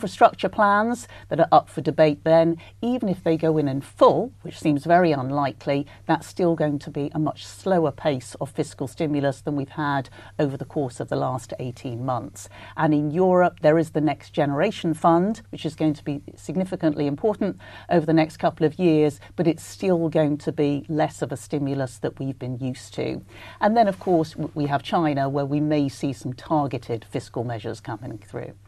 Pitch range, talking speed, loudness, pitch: 135-165 Hz, 200 wpm, -23 LUFS, 150 Hz